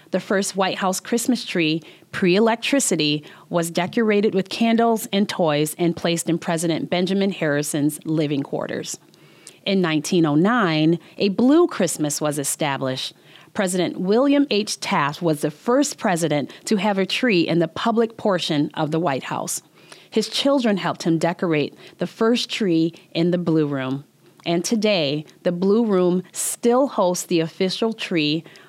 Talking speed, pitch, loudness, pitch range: 150 wpm, 180 Hz, -21 LUFS, 160-210 Hz